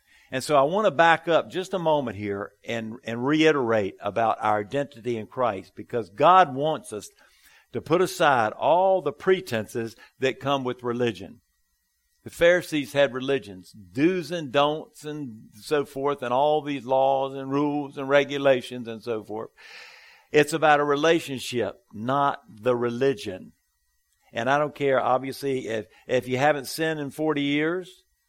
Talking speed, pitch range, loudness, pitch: 155 wpm, 120-150 Hz, -24 LUFS, 135 Hz